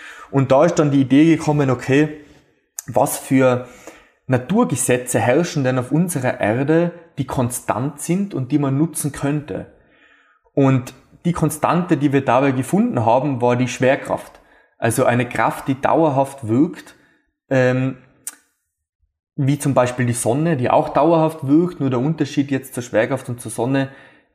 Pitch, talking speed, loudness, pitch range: 135 Hz, 145 wpm, -18 LUFS, 125-150 Hz